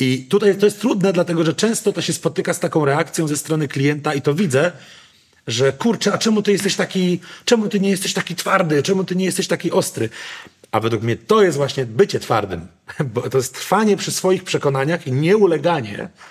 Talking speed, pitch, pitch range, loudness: 205 wpm, 175 Hz, 145-195 Hz, -18 LUFS